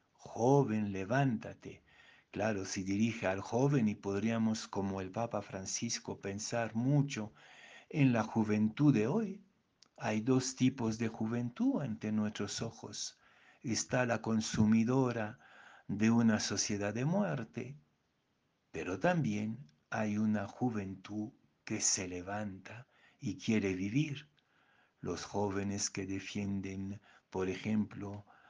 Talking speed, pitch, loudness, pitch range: 110 wpm, 110 Hz, -35 LUFS, 100-120 Hz